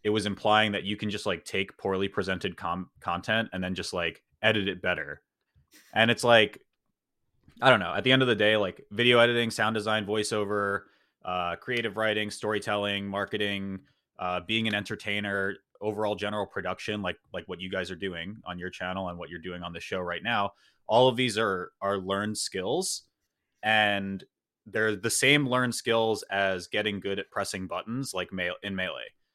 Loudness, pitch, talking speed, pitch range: -28 LUFS, 105 Hz, 190 wpm, 95-110 Hz